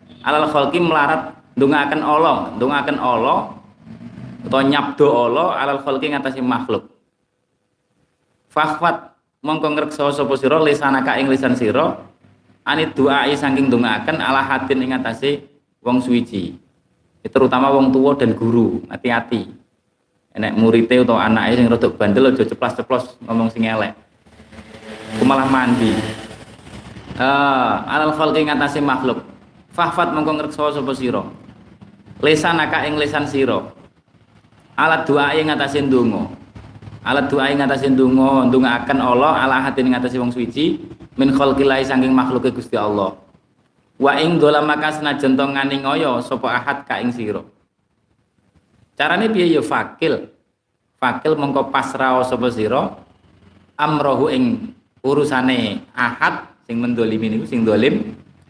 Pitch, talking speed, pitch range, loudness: 135 Hz, 130 wpm, 120-145 Hz, -17 LUFS